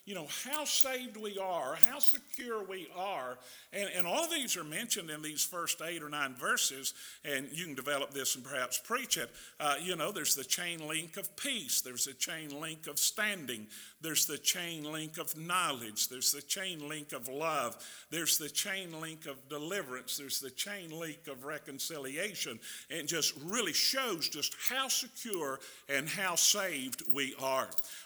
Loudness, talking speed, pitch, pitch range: -33 LUFS, 180 wpm, 160 Hz, 140-200 Hz